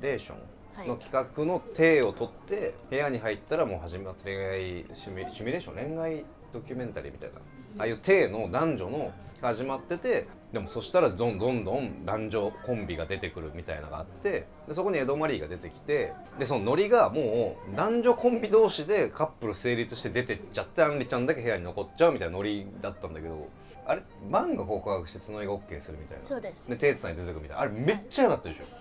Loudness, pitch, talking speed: -29 LUFS, 115 Hz, 475 characters per minute